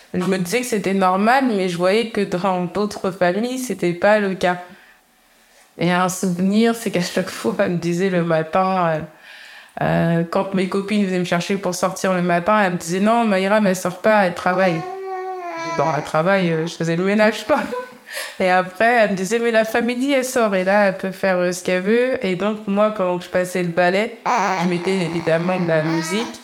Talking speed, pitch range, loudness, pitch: 210 wpm, 180-215 Hz, -19 LUFS, 190 Hz